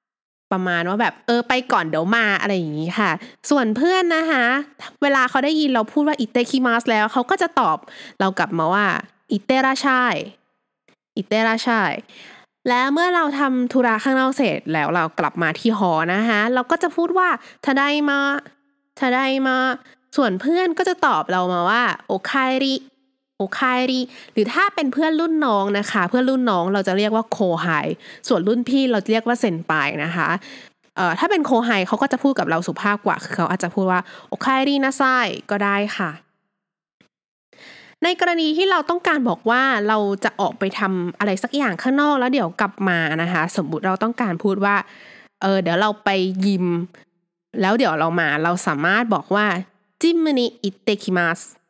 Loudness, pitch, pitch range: -19 LUFS, 225 Hz, 190-270 Hz